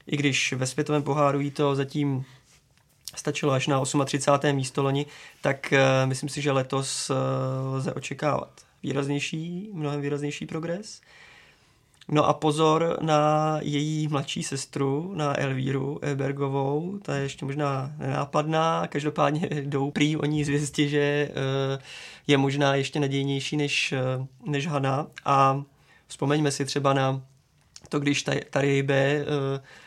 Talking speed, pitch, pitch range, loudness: 130 wpm, 140 Hz, 135-150 Hz, -26 LUFS